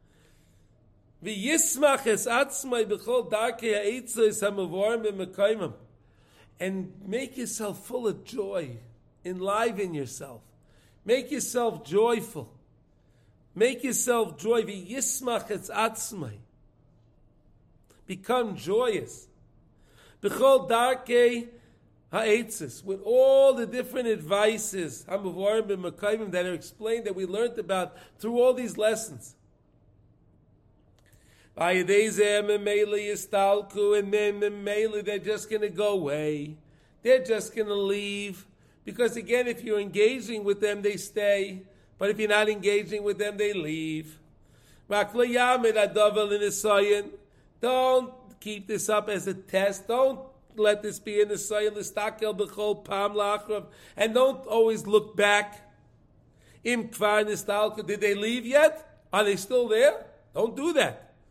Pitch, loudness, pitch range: 210 Hz, -26 LUFS, 190-225 Hz